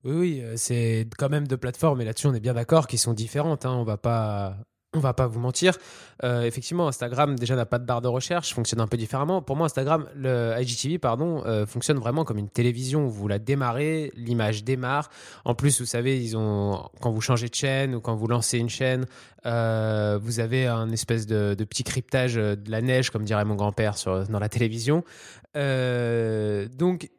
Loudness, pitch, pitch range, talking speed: -26 LUFS, 120 Hz, 115-135 Hz, 205 wpm